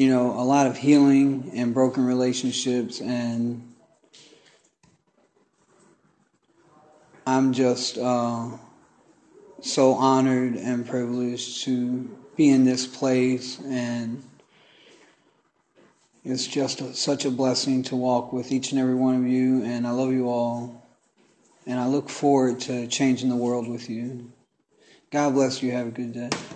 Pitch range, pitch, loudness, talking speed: 120-130 Hz, 125 Hz, -24 LUFS, 135 wpm